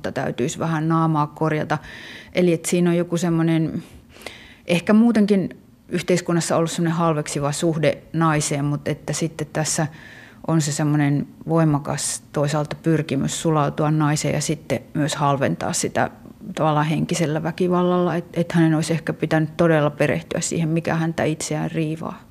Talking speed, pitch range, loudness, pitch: 135 wpm, 150-170 Hz, -21 LUFS, 160 Hz